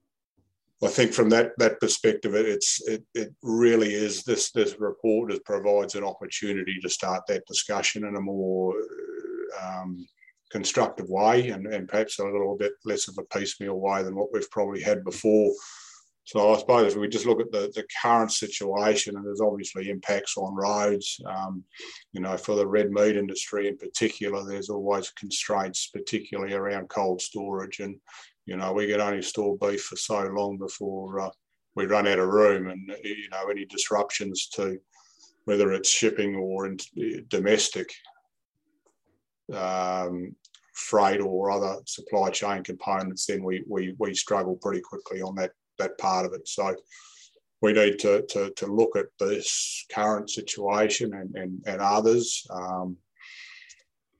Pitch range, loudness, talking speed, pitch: 95-120 Hz, -26 LUFS, 160 wpm, 100 Hz